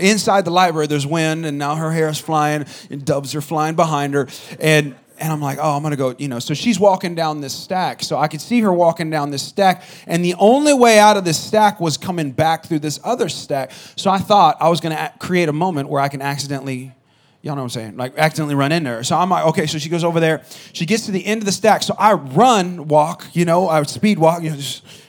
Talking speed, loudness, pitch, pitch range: 265 wpm, -17 LUFS, 160 Hz, 145-185 Hz